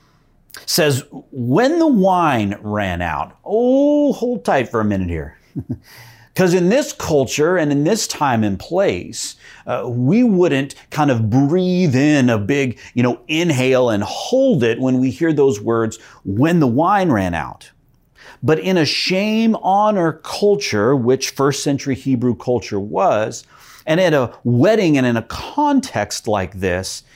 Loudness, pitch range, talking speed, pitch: -17 LUFS, 115-180 Hz, 155 wpm, 135 Hz